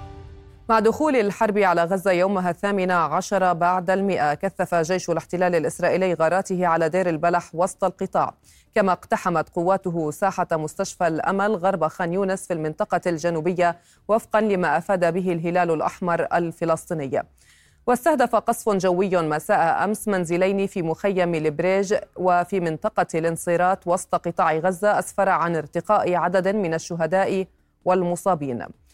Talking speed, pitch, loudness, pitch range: 125 wpm, 180 Hz, -22 LUFS, 170-195 Hz